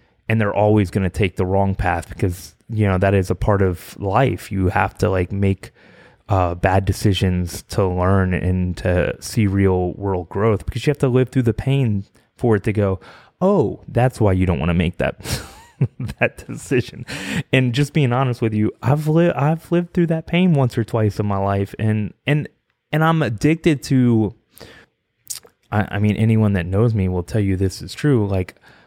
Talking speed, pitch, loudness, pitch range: 200 wpm, 105 Hz, -19 LUFS, 95-125 Hz